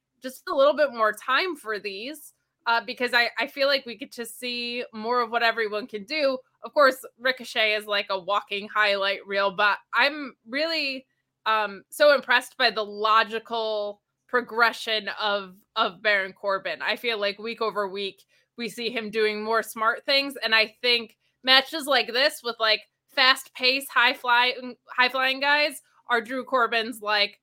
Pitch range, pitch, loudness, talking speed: 215-260 Hz, 230 Hz, -24 LUFS, 170 wpm